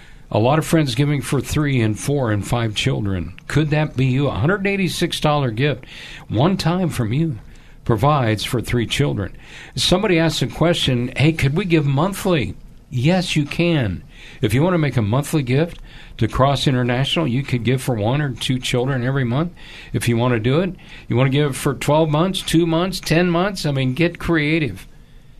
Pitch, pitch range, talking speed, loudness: 145 Hz, 125-165 Hz, 205 wpm, -19 LUFS